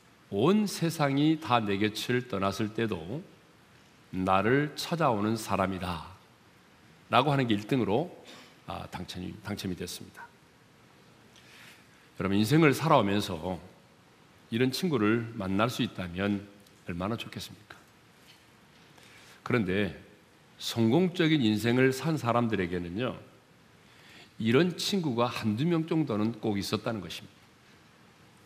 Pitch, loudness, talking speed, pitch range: 110 Hz, -29 LUFS, 230 characters per minute, 100-135 Hz